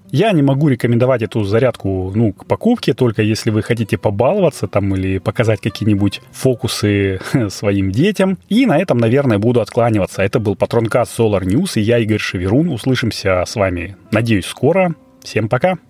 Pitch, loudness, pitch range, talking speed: 115 Hz, -16 LUFS, 100-130 Hz, 160 wpm